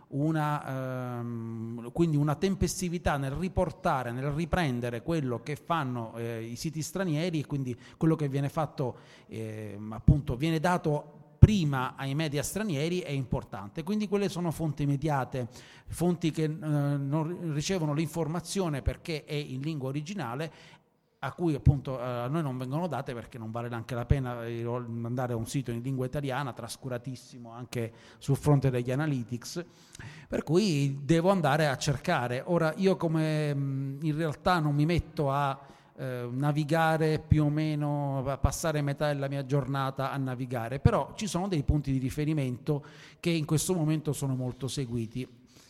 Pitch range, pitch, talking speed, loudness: 125-160 Hz, 145 Hz, 150 wpm, -30 LUFS